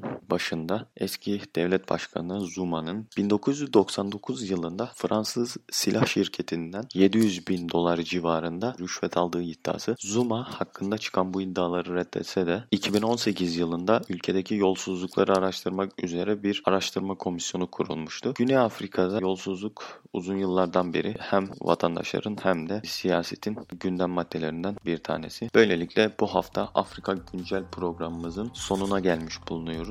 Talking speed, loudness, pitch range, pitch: 115 wpm, -27 LUFS, 85-100 Hz, 95 Hz